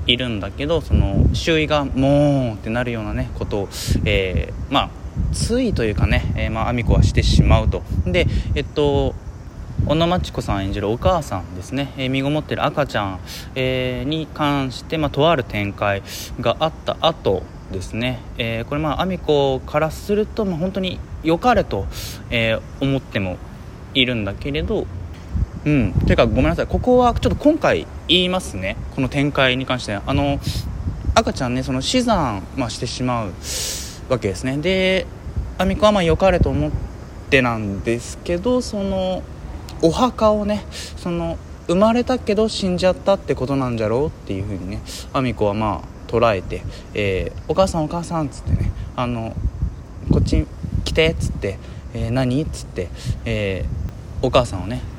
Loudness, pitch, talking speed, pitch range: -20 LUFS, 125 Hz, 330 characters per minute, 100-155 Hz